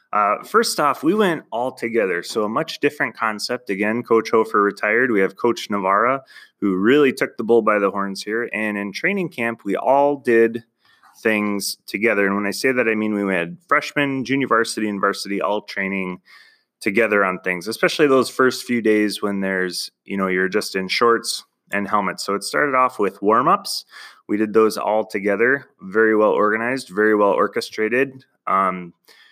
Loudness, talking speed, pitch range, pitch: -19 LUFS, 185 wpm, 100-120 Hz, 110 Hz